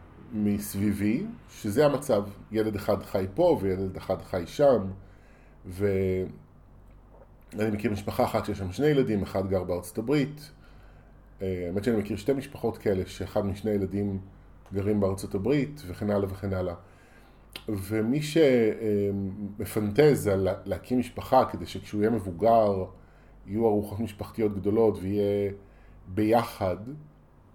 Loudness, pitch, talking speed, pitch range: -28 LUFS, 100 Hz, 120 wpm, 95-110 Hz